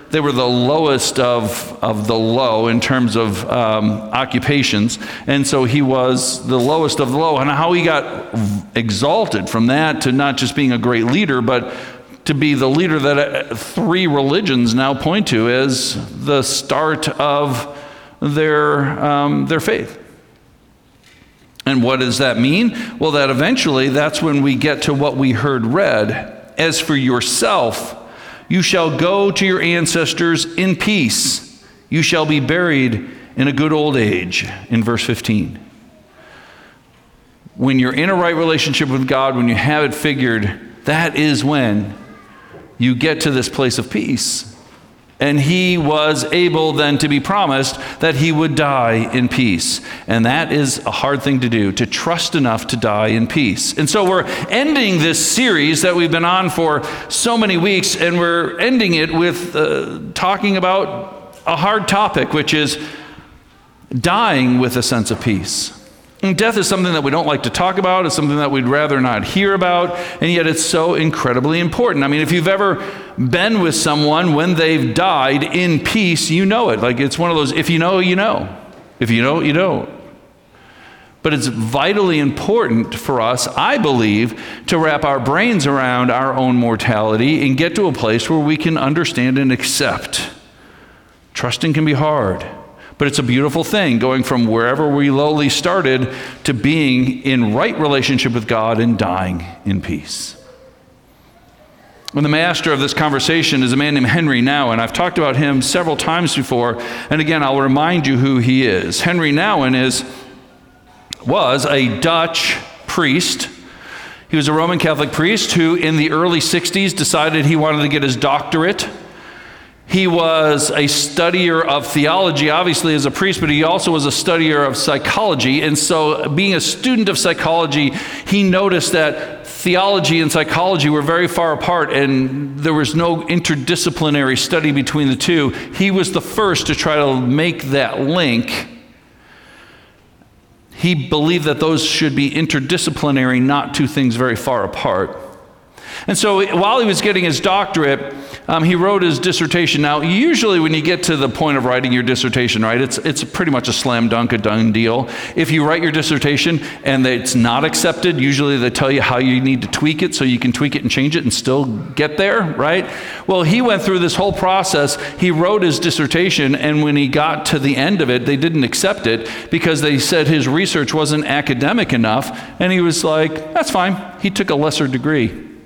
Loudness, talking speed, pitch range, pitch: -15 LUFS, 175 wpm, 130-170 Hz, 150 Hz